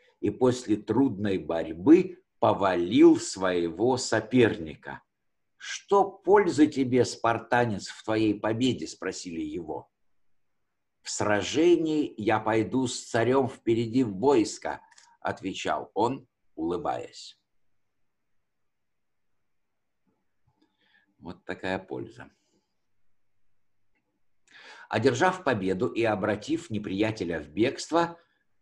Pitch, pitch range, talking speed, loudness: 115 Hz, 105-165 Hz, 80 wpm, -26 LUFS